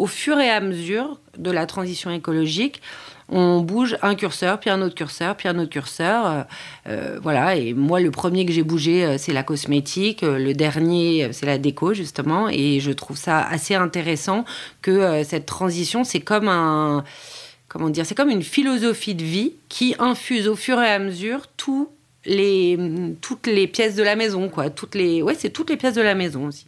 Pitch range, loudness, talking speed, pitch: 160-215 Hz, -21 LUFS, 195 wpm, 180 Hz